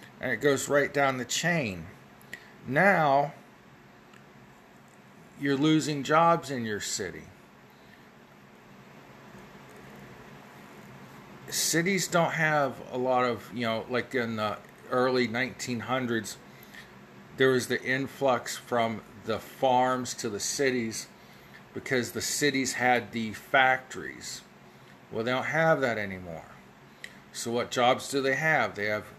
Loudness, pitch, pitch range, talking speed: -27 LUFS, 125 Hz, 115-140 Hz, 115 wpm